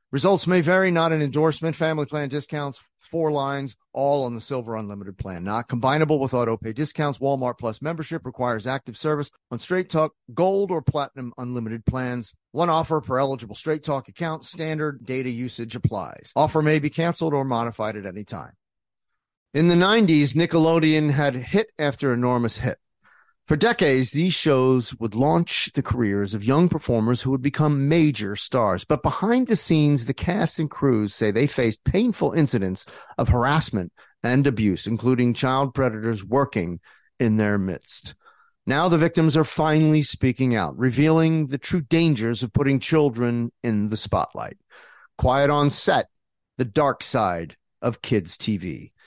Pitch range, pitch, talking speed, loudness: 120-155 Hz, 135 Hz, 160 wpm, -22 LUFS